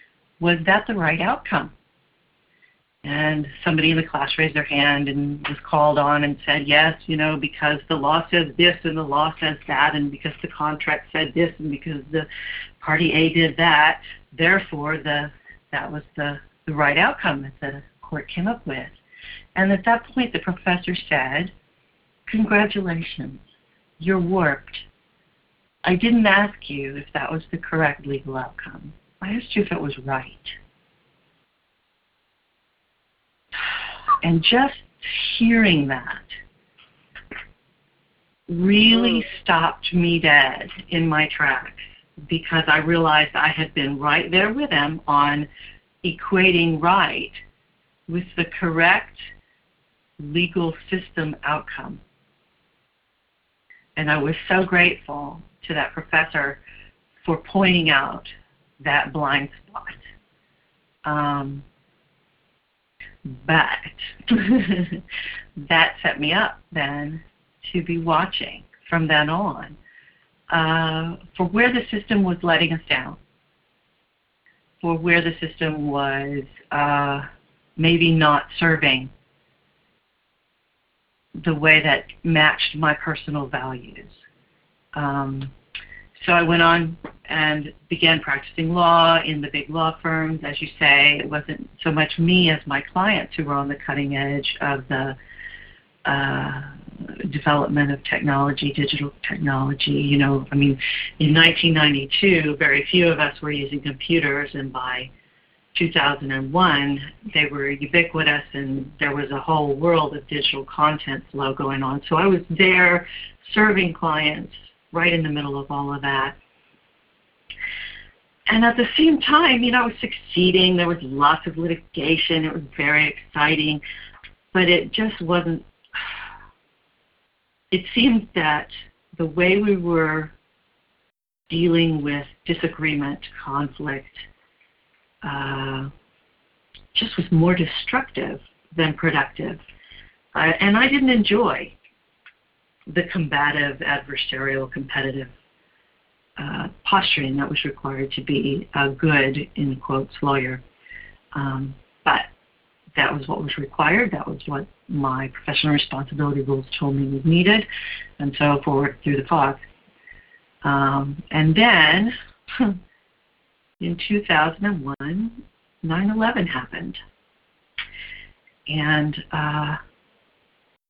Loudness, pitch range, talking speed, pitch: -20 LUFS, 145-175 Hz, 120 wpm, 155 Hz